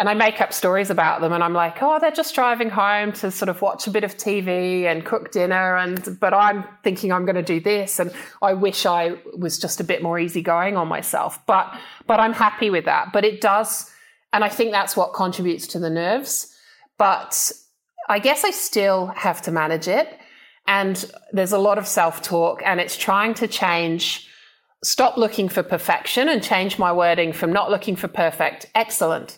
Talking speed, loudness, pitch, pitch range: 205 wpm, -20 LUFS, 195 Hz, 180-215 Hz